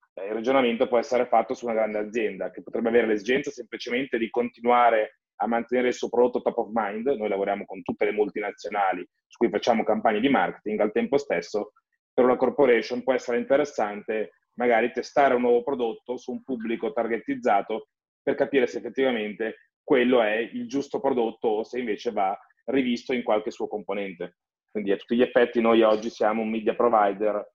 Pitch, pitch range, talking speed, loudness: 120 Hz, 110-130 Hz, 180 wpm, -25 LUFS